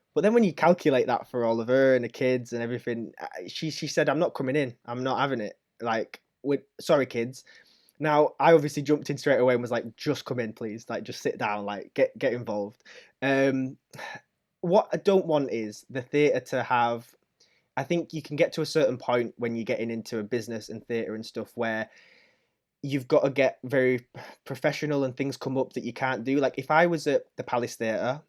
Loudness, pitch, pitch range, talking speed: -27 LUFS, 130 Hz, 120-150 Hz, 220 wpm